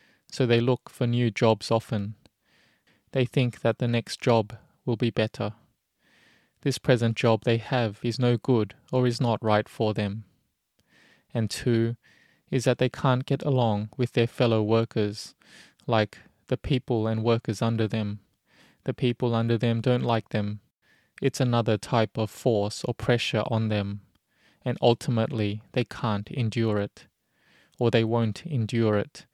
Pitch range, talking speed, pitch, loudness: 110-125 Hz, 155 wpm, 115 Hz, -26 LUFS